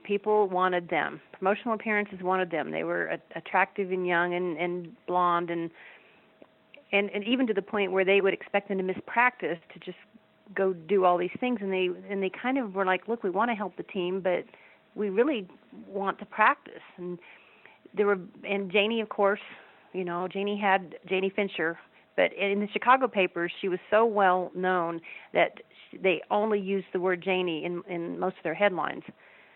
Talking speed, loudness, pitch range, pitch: 190 wpm, -28 LUFS, 180-205 Hz, 190 Hz